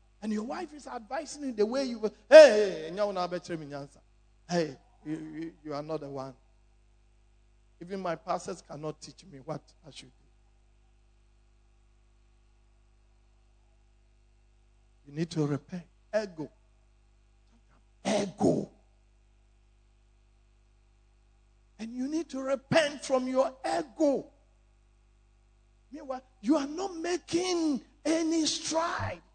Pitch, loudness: 135 Hz, -29 LUFS